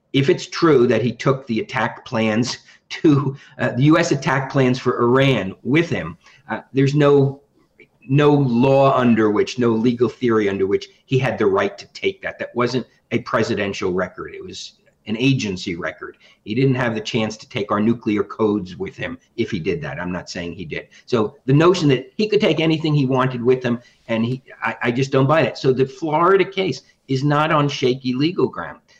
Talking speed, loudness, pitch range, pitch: 205 wpm, -19 LUFS, 120-150 Hz, 135 Hz